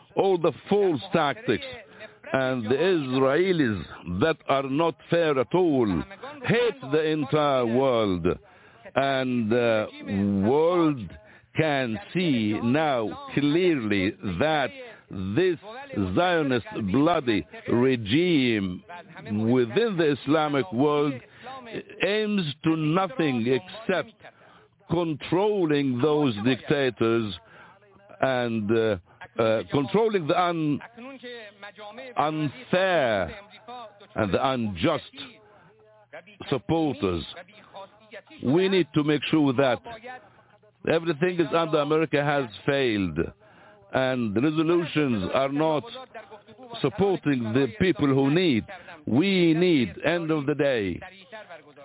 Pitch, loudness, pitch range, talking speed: 150 Hz, -25 LUFS, 125-180 Hz, 95 wpm